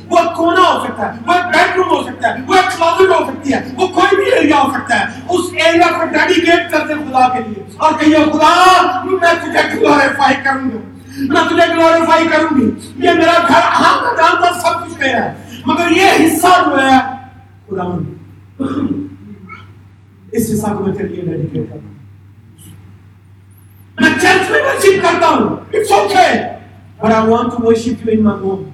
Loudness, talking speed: -12 LUFS, 190 wpm